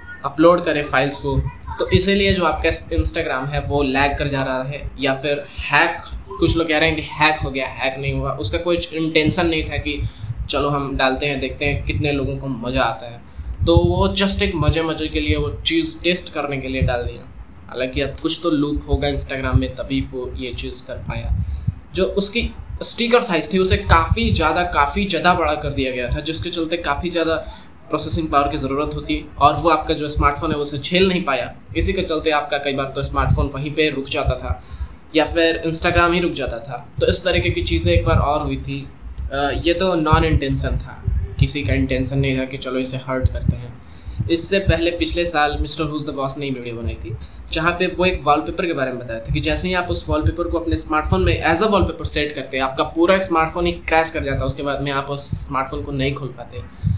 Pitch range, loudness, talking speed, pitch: 130-160 Hz, -19 LUFS, 230 wpm, 145 Hz